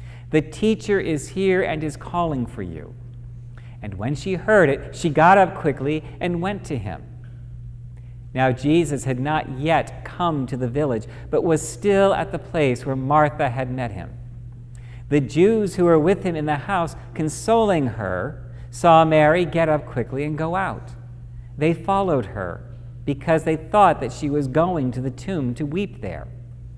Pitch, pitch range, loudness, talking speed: 140 Hz, 120-160 Hz, -21 LUFS, 175 wpm